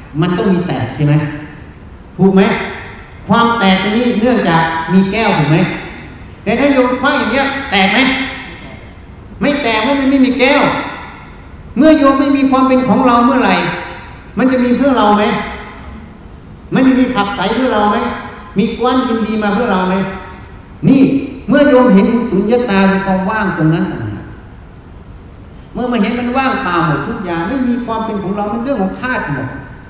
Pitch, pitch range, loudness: 215 Hz, 180-255 Hz, -13 LUFS